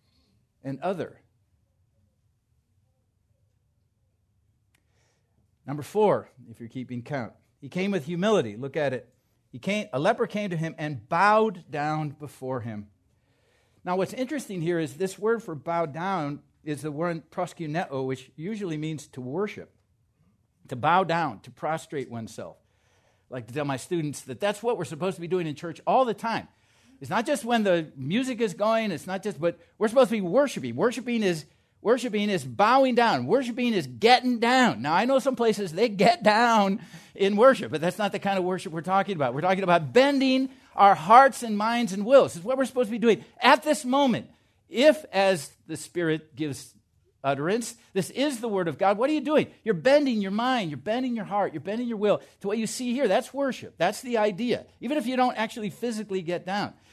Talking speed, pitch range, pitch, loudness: 195 wpm, 140-230 Hz, 185 Hz, -25 LUFS